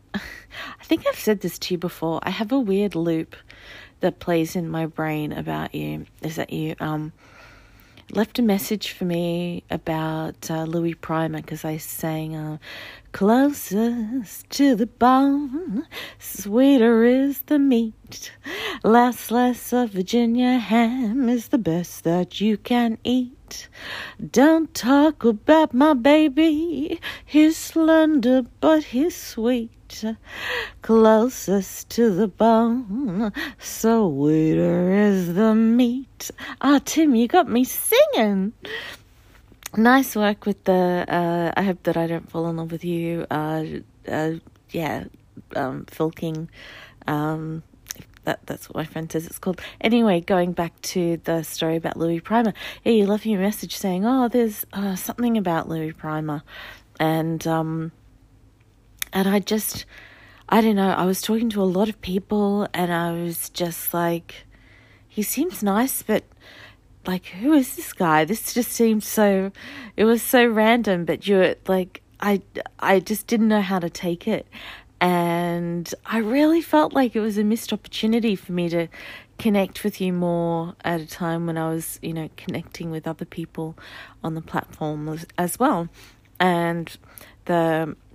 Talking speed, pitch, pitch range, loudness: 150 wpm, 190 Hz, 165-235 Hz, -22 LUFS